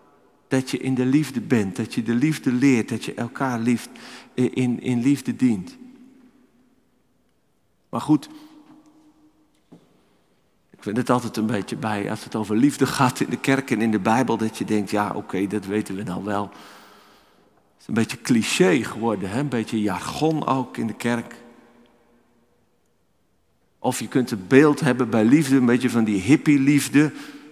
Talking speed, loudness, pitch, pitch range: 170 wpm, -22 LUFS, 120 Hz, 110-145 Hz